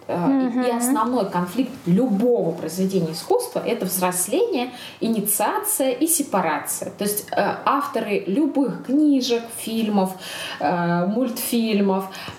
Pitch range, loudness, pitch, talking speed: 190-265 Hz, -22 LUFS, 230 Hz, 85 wpm